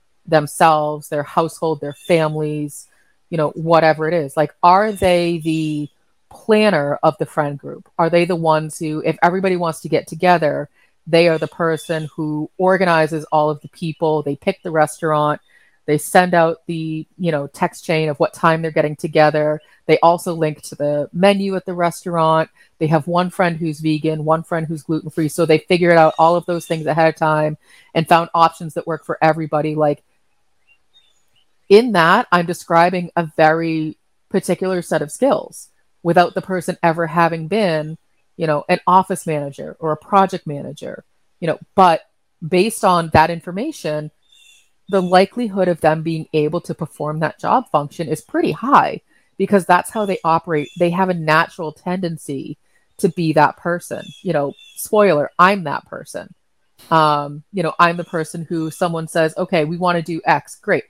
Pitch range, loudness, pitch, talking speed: 155-180 Hz, -17 LUFS, 165 Hz, 175 wpm